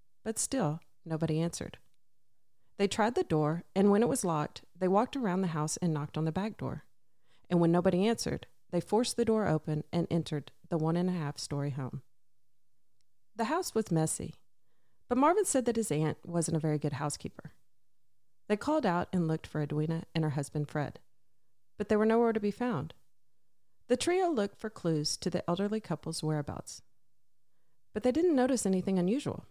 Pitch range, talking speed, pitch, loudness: 155-220 Hz, 185 wpm, 175 Hz, -32 LUFS